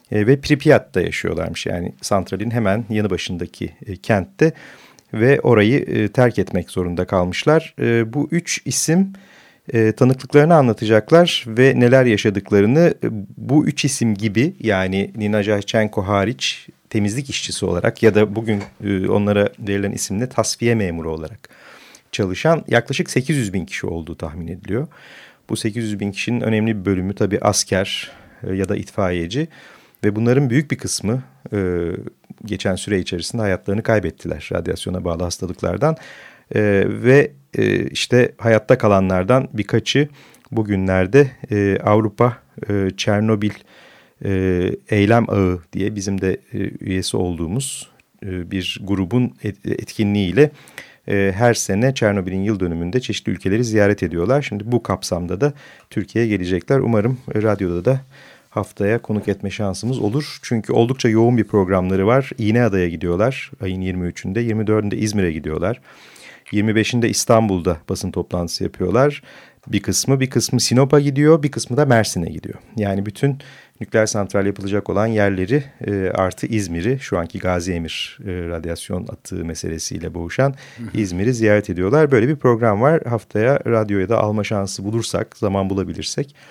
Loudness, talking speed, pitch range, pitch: -19 LUFS, 125 wpm, 95-125 Hz, 105 Hz